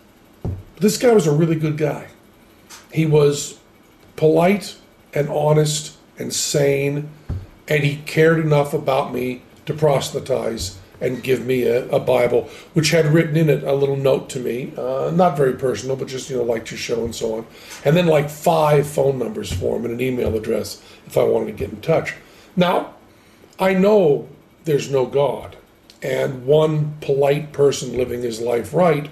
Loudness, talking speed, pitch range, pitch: -19 LUFS, 175 wpm, 125-155 Hz, 145 Hz